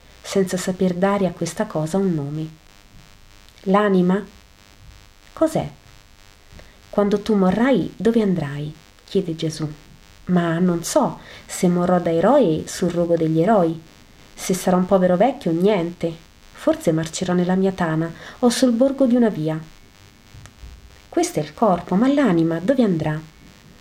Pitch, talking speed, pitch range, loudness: 175 Hz, 135 wpm, 155-195 Hz, -20 LUFS